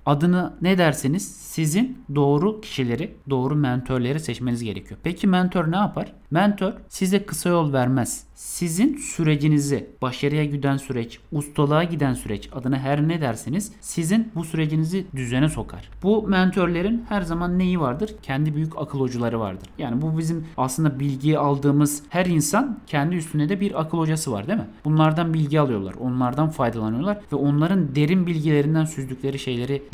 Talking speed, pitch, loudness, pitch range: 150 wpm, 150 Hz, -23 LUFS, 135-175 Hz